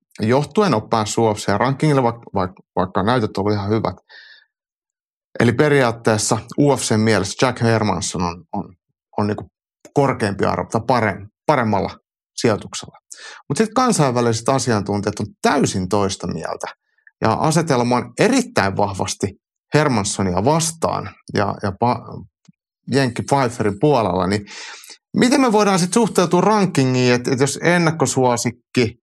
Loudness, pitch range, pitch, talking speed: -18 LUFS, 105-145 Hz, 120 Hz, 120 wpm